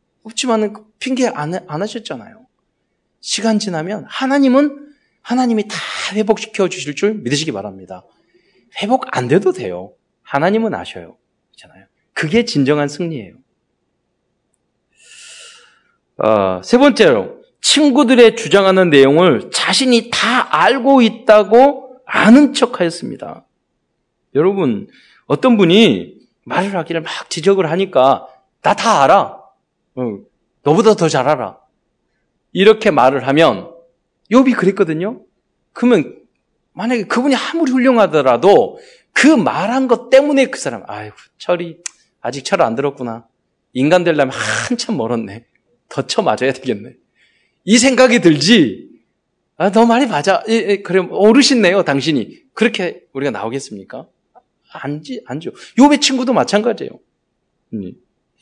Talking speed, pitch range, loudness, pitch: 255 characters per minute, 165-250 Hz, -14 LUFS, 215 Hz